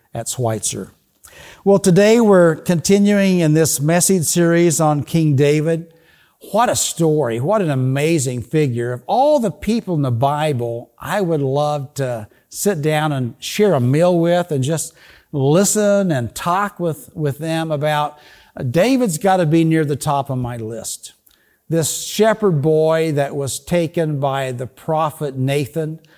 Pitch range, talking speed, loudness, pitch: 140-175 Hz, 155 wpm, -17 LUFS, 155 Hz